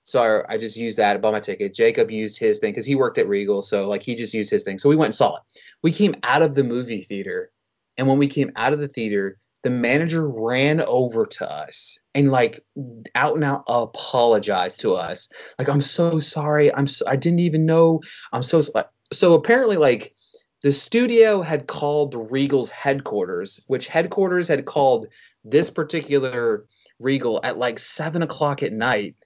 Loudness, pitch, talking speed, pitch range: -21 LUFS, 145 Hz, 195 wpm, 125-165 Hz